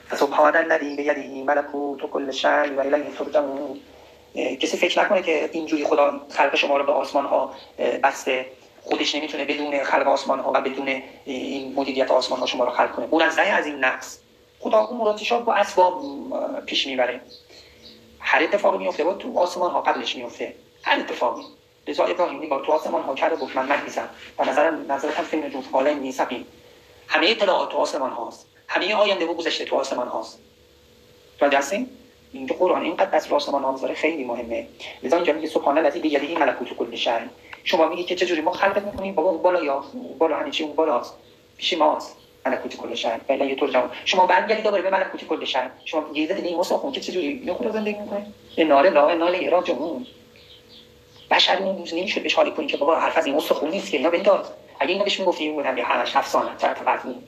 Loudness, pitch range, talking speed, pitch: -22 LUFS, 145-205 Hz, 170 wpm, 170 Hz